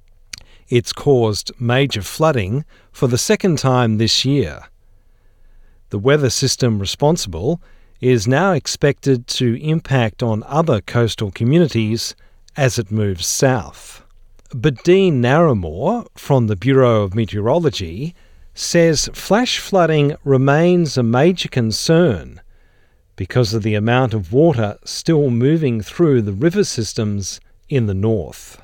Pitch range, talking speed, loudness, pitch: 105-145 Hz, 120 wpm, -17 LUFS, 120 Hz